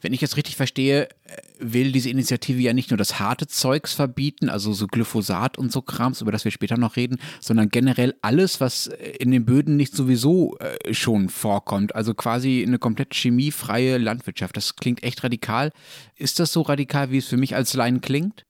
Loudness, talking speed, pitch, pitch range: -22 LUFS, 190 wpm, 125 Hz, 115-140 Hz